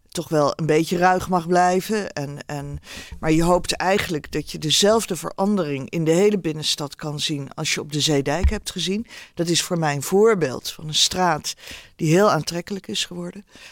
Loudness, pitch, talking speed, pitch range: -21 LUFS, 175 Hz, 195 wpm, 150-190 Hz